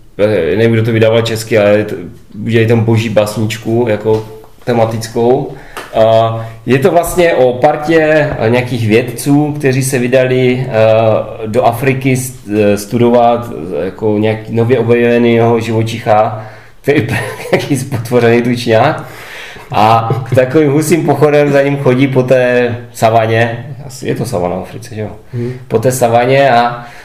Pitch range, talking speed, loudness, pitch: 115-130 Hz, 120 wpm, -11 LUFS, 120 Hz